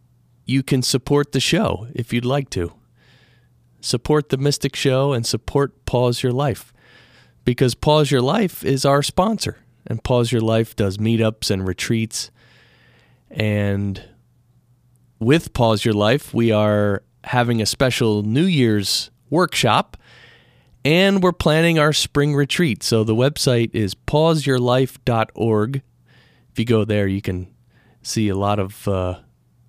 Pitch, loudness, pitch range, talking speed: 120 Hz, -19 LUFS, 110-135 Hz, 135 wpm